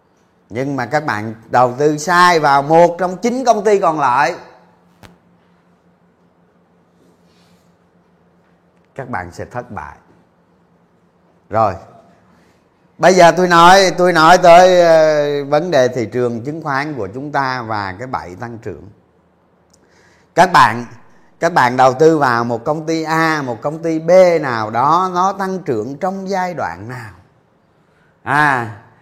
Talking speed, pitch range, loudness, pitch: 140 wpm, 105-165 Hz, -13 LUFS, 135 Hz